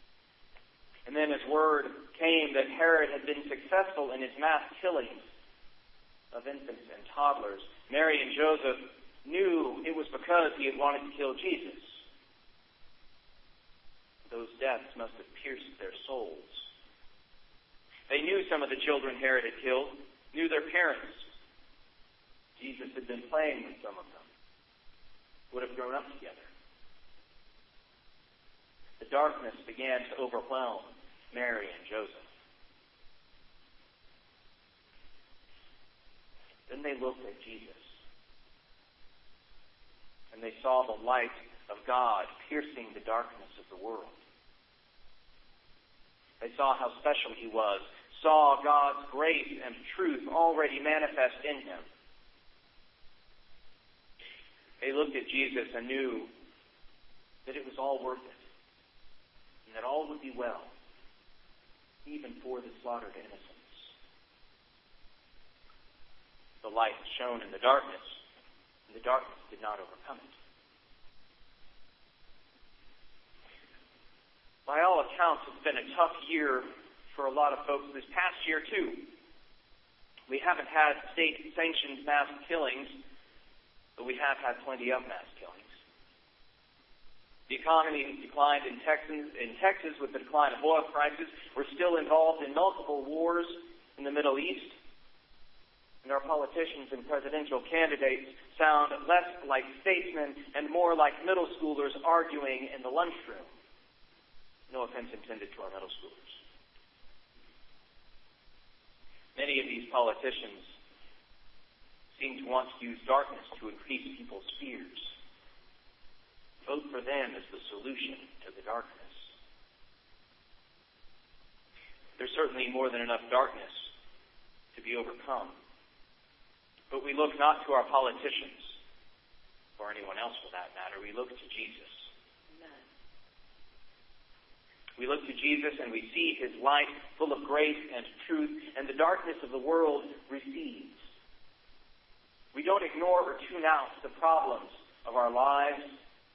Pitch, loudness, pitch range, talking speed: 145 Hz, -32 LUFS, 130-165 Hz, 125 wpm